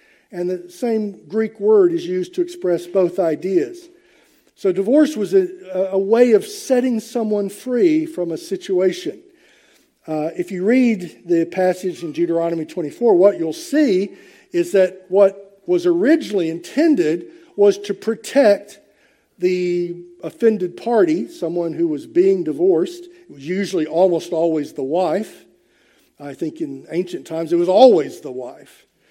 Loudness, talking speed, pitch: -18 LUFS, 145 wpm, 205 Hz